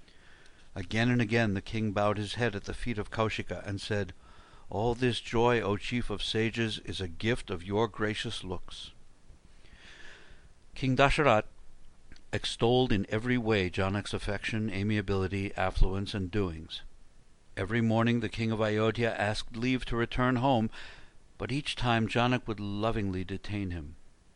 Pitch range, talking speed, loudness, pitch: 95-115 Hz, 150 wpm, -31 LUFS, 105 Hz